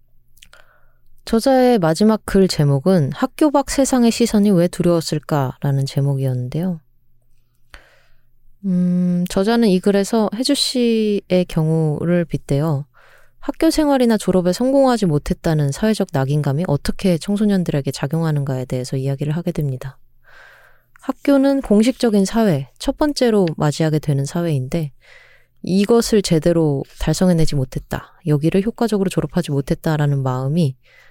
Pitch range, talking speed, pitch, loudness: 145-215 Hz, 310 characters per minute, 175 Hz, -18 LUFS